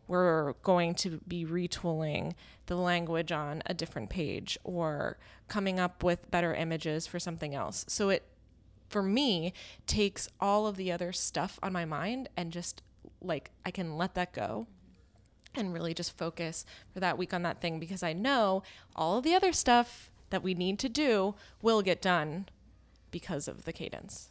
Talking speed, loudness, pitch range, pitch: 175 wpm, -33 LUFS, 165-190 Hz, 175 Hz